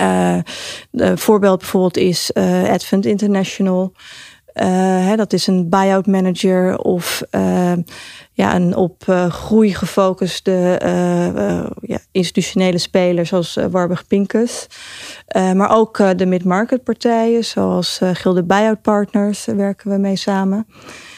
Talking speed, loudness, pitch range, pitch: 135 wpm, -16 LUFS, 180-205 Hz, 190 Hz